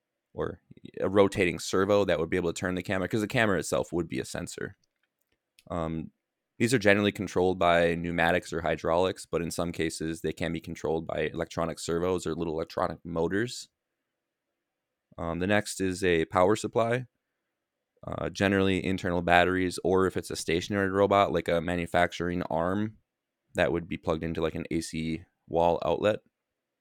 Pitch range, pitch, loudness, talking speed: 85-100 Hz, 90 Hz, -28 LUFS, 170 wpm